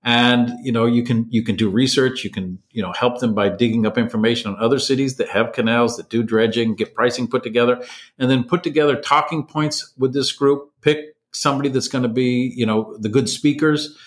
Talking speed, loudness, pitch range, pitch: 220 wpm, -19 LUFS, 115-140 Hz, 125 Hz